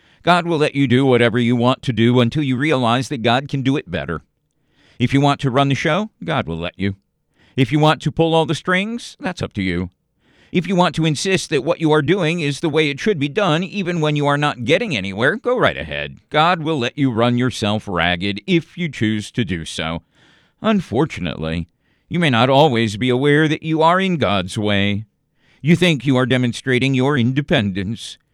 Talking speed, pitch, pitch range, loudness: 215 wpm, 135 Hz, 115-160 Hz, -18 LUFS